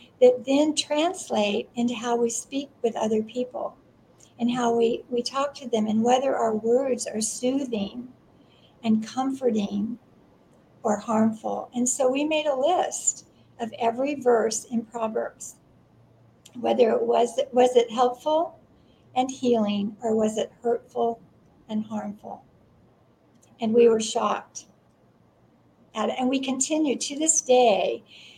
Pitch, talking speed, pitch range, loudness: 240 Hz, 135 wpm, 220-260 Hz, -25 LUFS